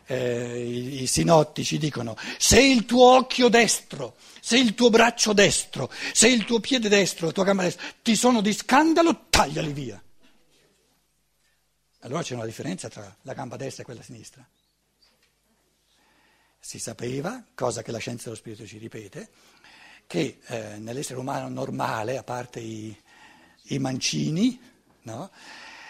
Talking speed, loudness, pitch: 140 wpm, -22 LUFS, 155 Hz